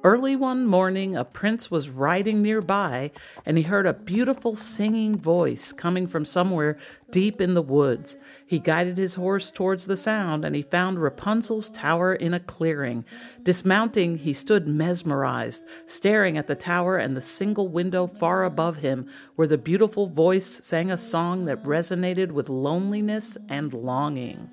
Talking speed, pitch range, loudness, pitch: 160 wpm, 160-200 Hz, -24 LUFS, 180 Hz